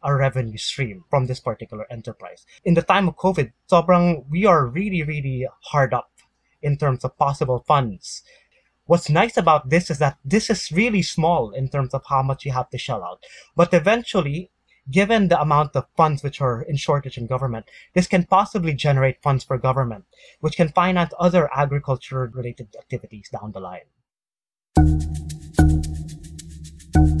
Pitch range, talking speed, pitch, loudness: 125-170 Hz, 160 wpm, 140 Hz, -21 LUFS